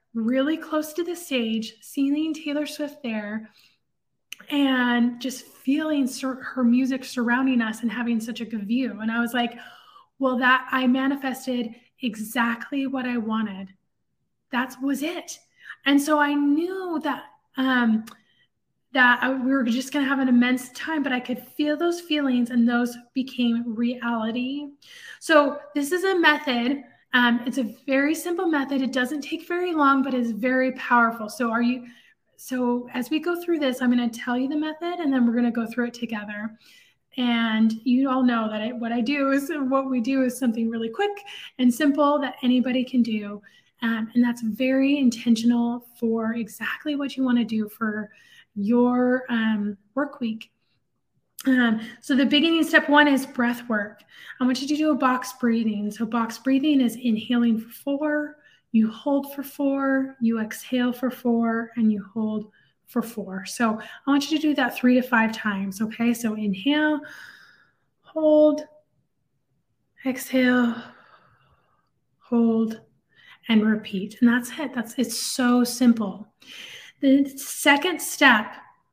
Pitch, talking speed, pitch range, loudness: 250 Hz, 165 wpm, 230-280 Hz, -23 LUFS